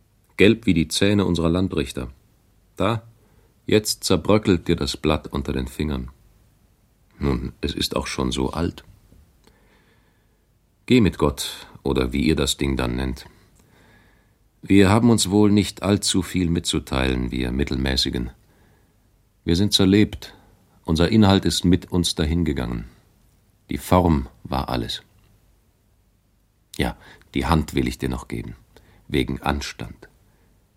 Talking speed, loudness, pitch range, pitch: 125 wpm, -21 LUFS, 70-100 Hz, 90 Hz